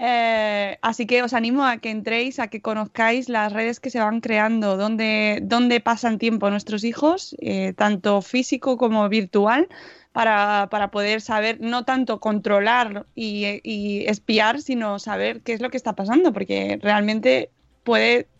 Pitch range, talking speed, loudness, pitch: 210-240 Hz, 155 wpm, -21 LUFS, 225 Hz